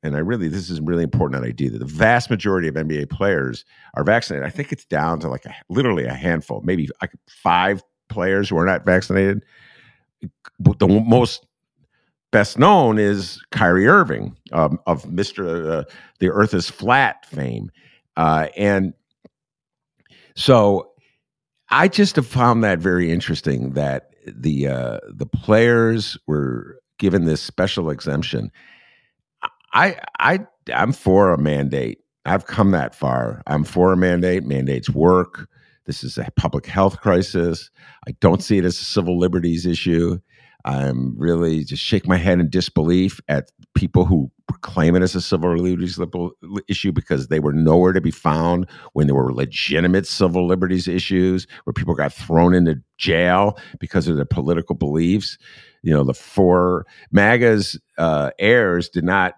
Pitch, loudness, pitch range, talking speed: 90 Hz, -19 LUFS, 80-100 Hz, 160 wpm